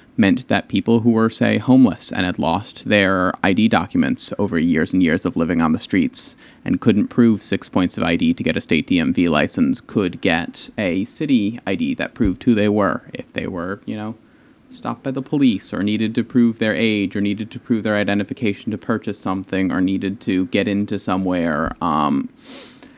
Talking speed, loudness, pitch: 200 wpm, -19 LUFS, 115 Hz